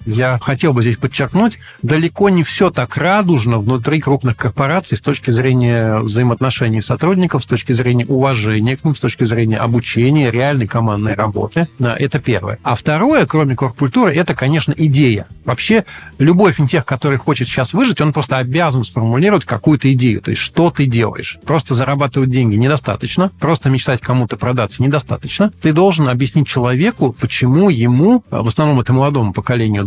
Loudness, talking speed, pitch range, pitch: -14 LUFS, 160 wpm, 120-155 Hz, 135 Hz